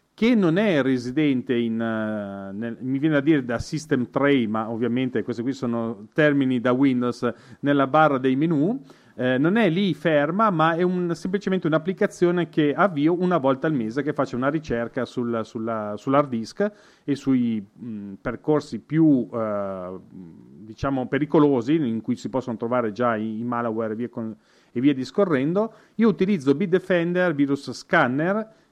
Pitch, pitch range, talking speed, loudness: 135 Hz, 115-160 Hz, 160 wpm, -23 LUFS